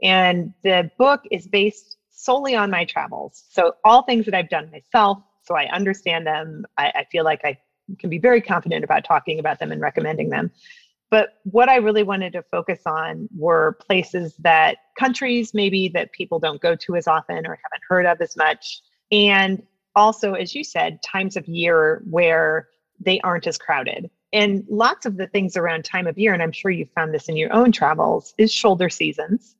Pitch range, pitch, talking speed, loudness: 165-215 Hz, 190 Hz, 195 wpm, -19 LUFS